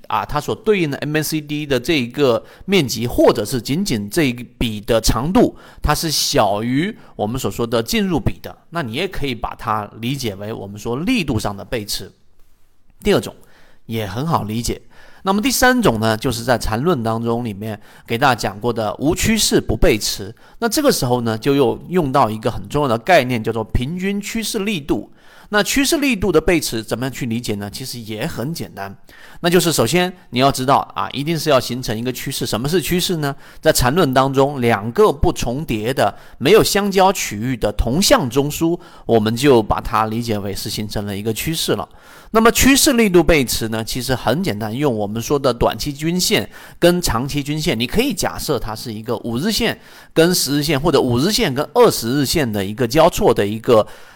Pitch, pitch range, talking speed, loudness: 130 Hz, 110-165 Hz, 295 characters per minute, -18 LUFS